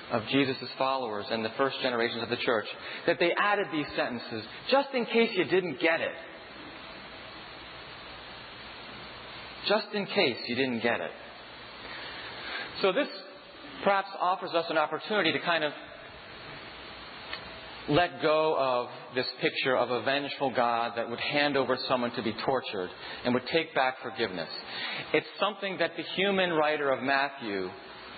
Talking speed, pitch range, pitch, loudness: 145 wpm, 125-175 Hz, 140 Hz, -29 LUFS